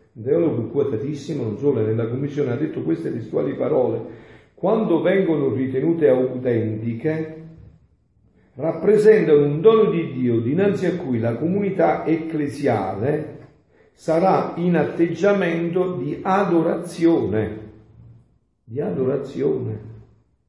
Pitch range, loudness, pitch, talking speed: 120-170 Hz, -20 LUFS, 150 Hz, 95 wpm